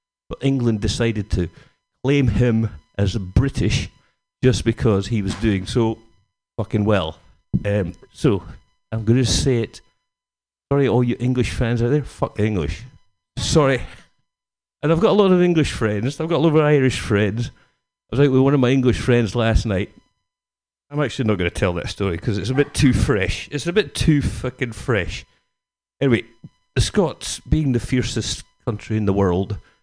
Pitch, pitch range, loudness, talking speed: 115 Hz, 100-130 Hz, -20 LUFS, 185 wpm